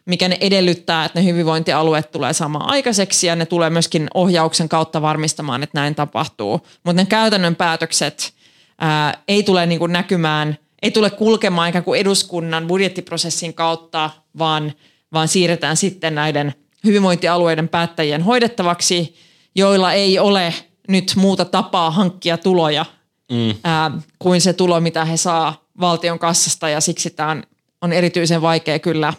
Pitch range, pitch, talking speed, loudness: 160-180 Hz, 170 Hz, 140 wpm, -17 LUFS